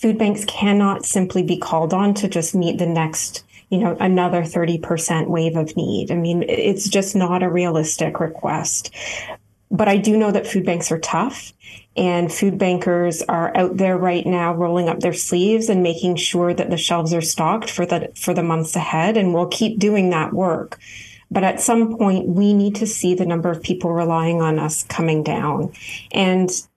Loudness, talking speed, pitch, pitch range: -19 LUFS, 195 wpm, 175 Hz, 170-195 Hz